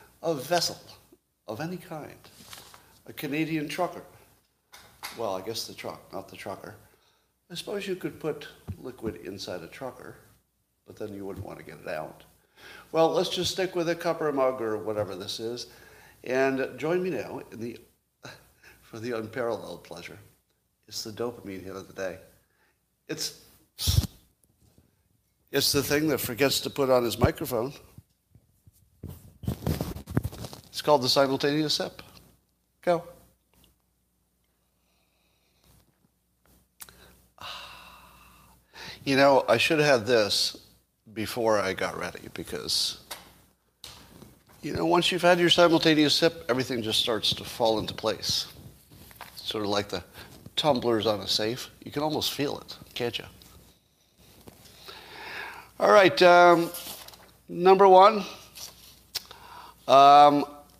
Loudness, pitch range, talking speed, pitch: -25 LUFS, 110-165 Hz, 130 wpm, 135 Hz